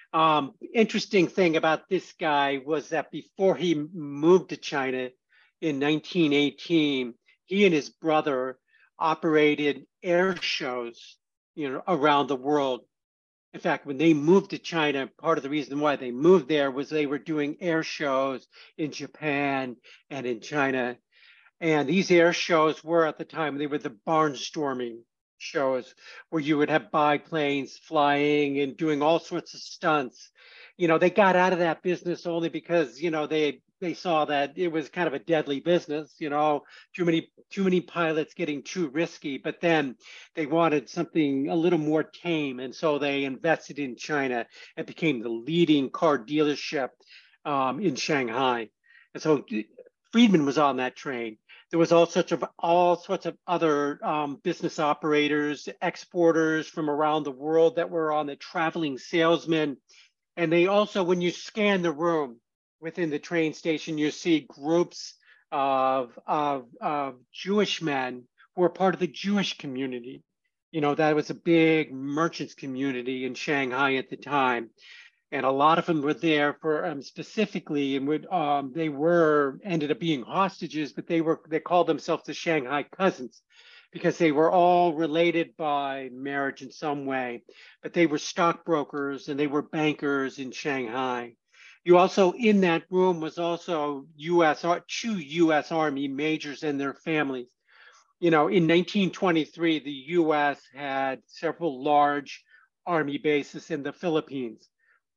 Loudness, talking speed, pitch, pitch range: -26 LUFS, 160 wpm, 155 Hz, 140-170 Hz